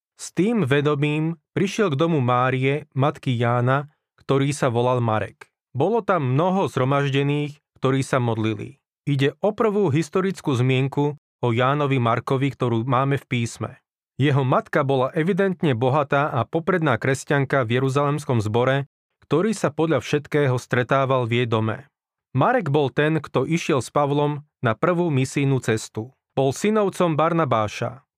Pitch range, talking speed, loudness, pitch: 130-155 Hz, 140 wpm, -22 LUFS, 140 Hz